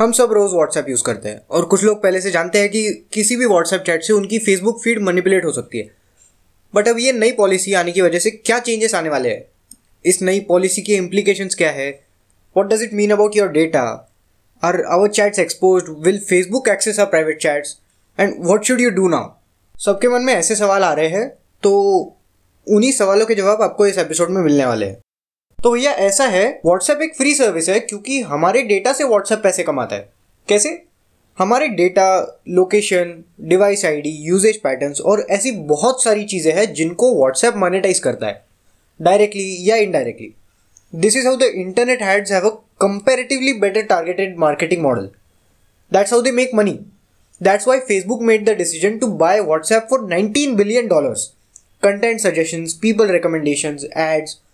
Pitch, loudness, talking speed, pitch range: 195 Hz, -16 LUFS, 185 wpm, 170-220 Hz